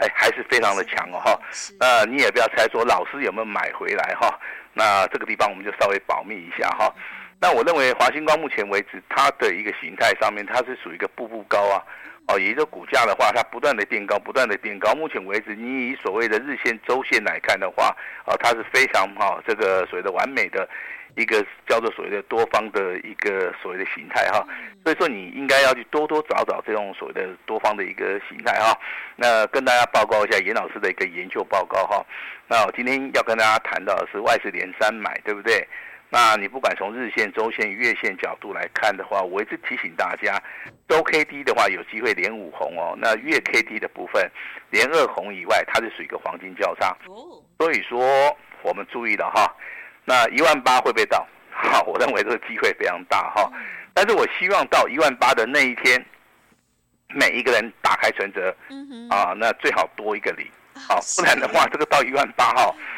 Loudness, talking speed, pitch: -21 LUFS, 315 characters per minute, 150 Hz